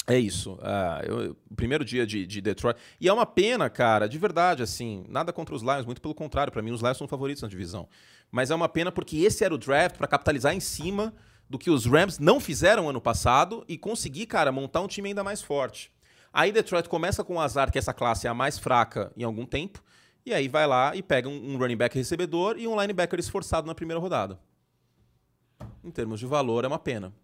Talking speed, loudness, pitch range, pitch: 230 wpm, -27 LUFS, 120-175 Hz, 140 Hz